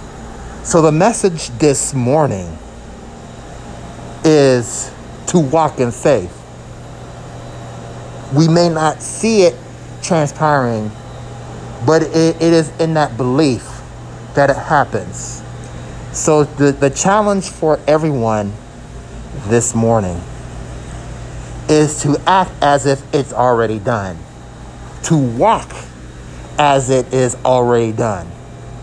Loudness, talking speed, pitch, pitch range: -14 LUFS, 100 wpm, 135 Hz, 115-155 Hz